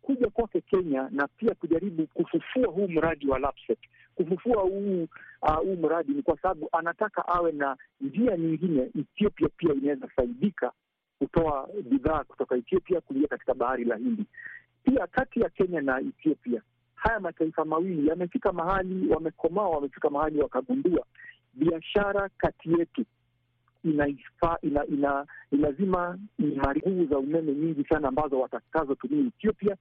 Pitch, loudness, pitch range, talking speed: 170 Hz, -28 LUFS, 145-210 Hz, 135 wpm